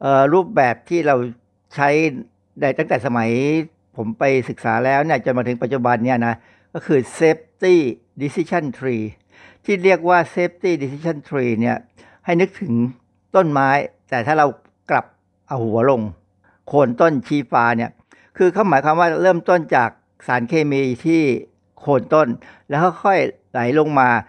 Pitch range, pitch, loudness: 120-165 Hz, 140 Hz, -18 LUFS